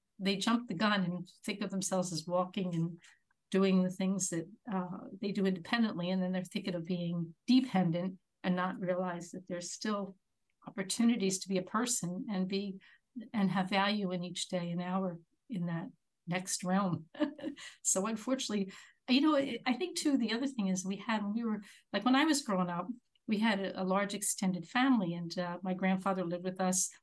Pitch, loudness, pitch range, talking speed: 190 Hz, -34 LUFS, 180-220 Hz, 190 wpm